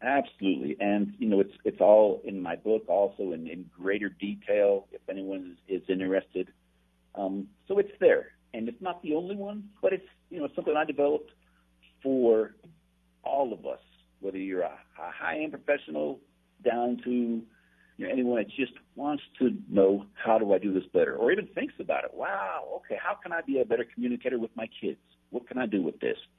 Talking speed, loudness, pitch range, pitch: 200 wpm, -29 LUFS, 90-145 Hz, 105 Hz